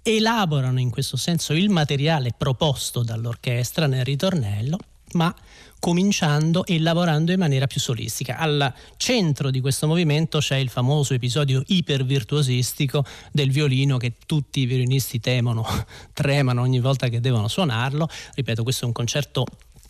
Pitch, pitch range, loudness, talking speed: 140 Hz, 125-155 Hz, -22 LUFS, 140 wpm